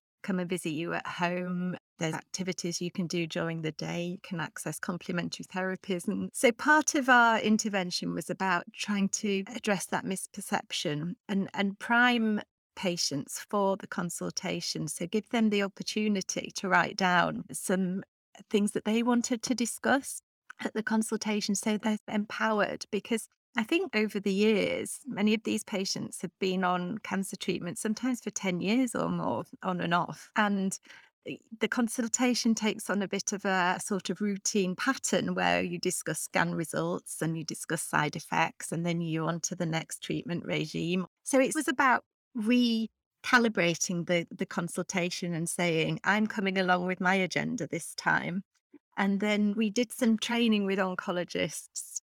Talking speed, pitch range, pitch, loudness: 165 wpm, 180-220 Hz, 195 Hz, -30 LUFS